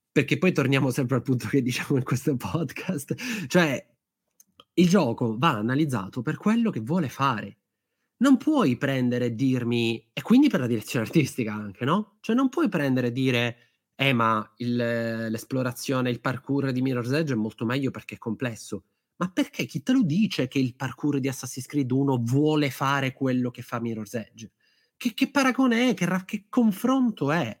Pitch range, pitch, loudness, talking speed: 120-175 Hz, 135 Hz, -25 LUFS, 180 wpm